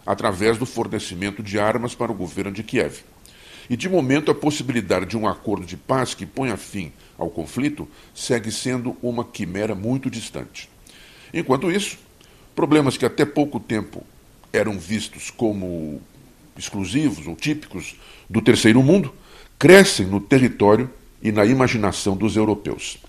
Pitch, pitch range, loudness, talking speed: 115 Hz, 100-130 Hz, -21 LUFS, 145 wpm